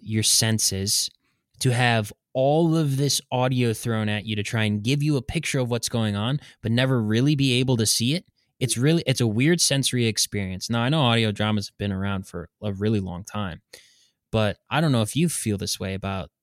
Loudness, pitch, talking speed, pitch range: -23 LUFS, 115 Hz, 220 wpm, 105-130 Hz